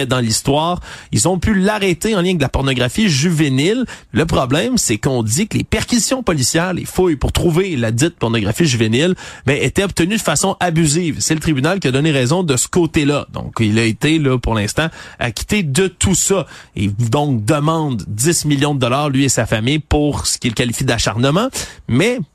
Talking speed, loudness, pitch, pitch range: 200 wpm, -16 LUFS, 150 Hz, 125-180 Hz